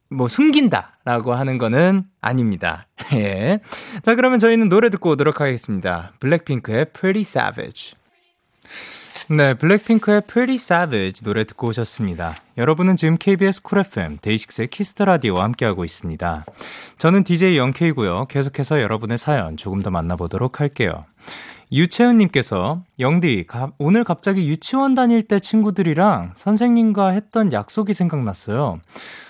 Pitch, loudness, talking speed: 155 Hz, -18 LUFS, 370 characters per minute